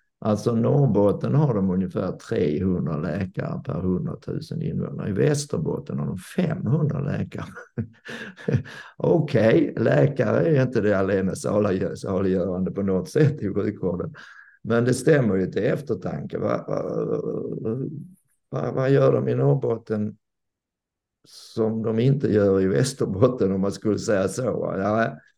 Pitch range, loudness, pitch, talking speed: 95-130 Hz, -23 LUFS, 110 Hz, 135 wpm